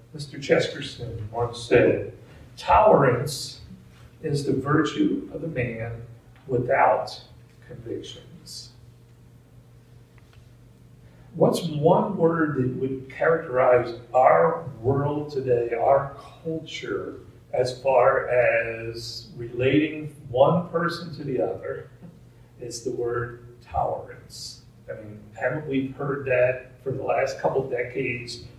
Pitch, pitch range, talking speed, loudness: 125 Hz, 120-145 Hz, 105 wpm, -24 LUFS